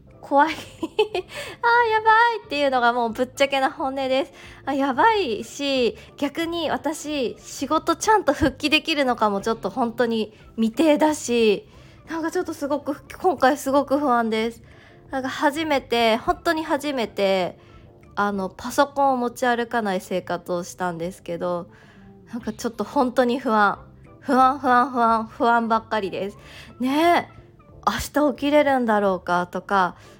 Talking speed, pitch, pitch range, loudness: 280 characters per minute, 260 Hz, 220-295 Hz, -22 LUFS